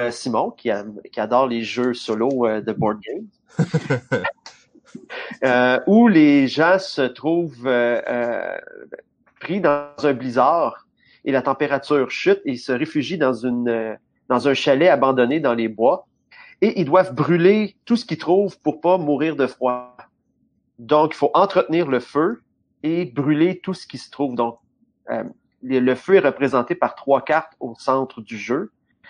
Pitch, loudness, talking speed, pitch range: 145 Hz, -20 LUFS, 165 wpm, 125-180 Hz